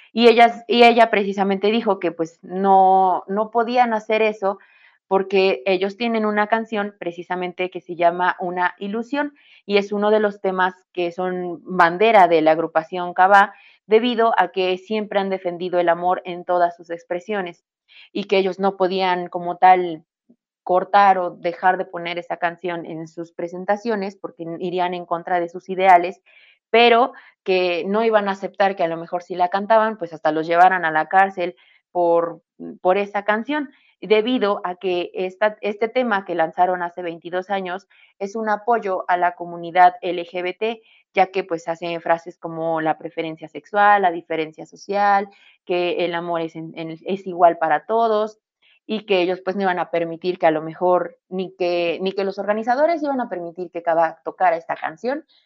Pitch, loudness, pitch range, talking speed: 185 Hz, -20 LUFS, 175-205 Hz, 175 wpm